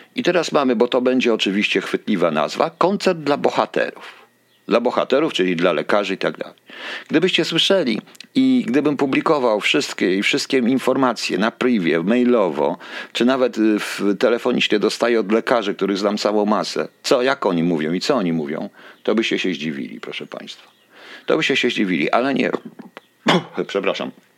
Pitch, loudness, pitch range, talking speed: 120 Hz, -19 LUFS, 105-165 Hz, 160 wpm